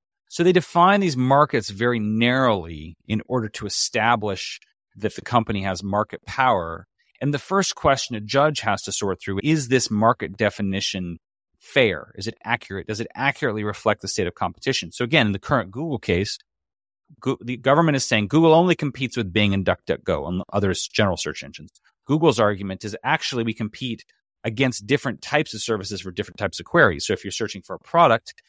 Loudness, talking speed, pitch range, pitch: -22 LUFS, 190 wpm, 100-135 Hz, 115 Hz